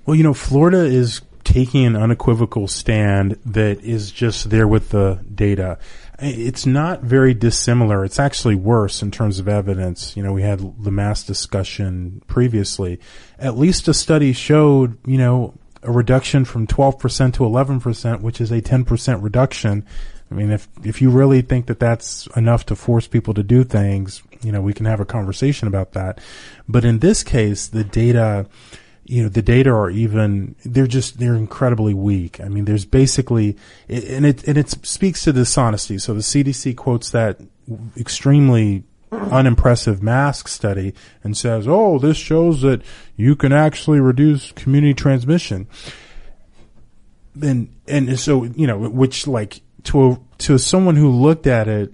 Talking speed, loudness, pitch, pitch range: 165 wpm, -17 LUFS, 120 Hz, 105-135 Hz